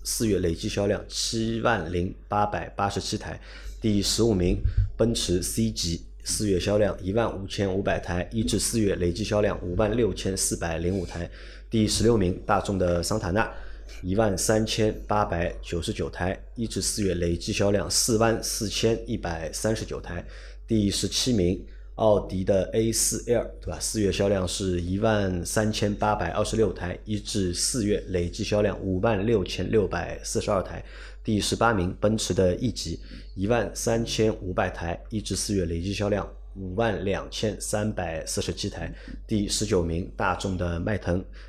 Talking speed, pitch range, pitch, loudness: 255 characters per minute, 90-110 Hz, 100 Hz, -26 LUFS